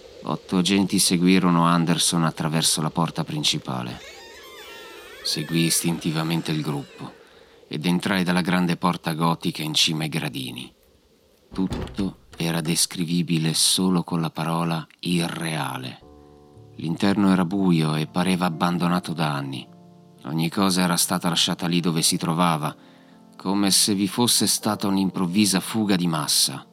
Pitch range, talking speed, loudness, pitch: 80-95 Hz, 125 wpm, -22 LUFS, 85 Hz